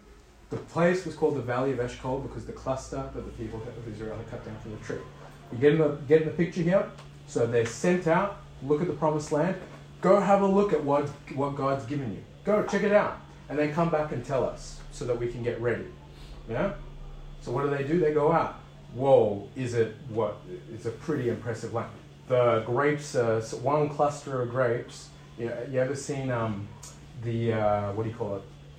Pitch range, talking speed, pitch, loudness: 115-150 Hz, 225 wpm, 135 Hz, -28 LUFS